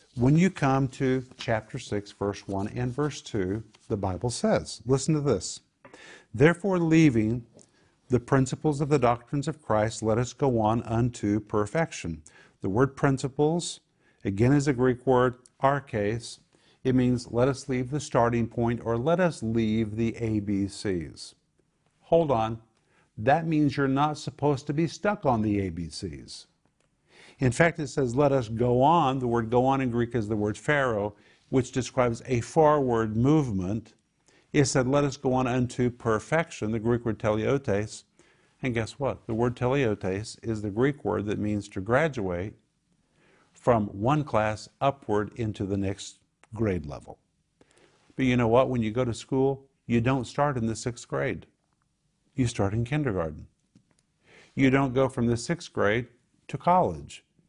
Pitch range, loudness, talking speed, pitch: 110-140 Hz, -27 LUFS, 165 wpm, 125 Hz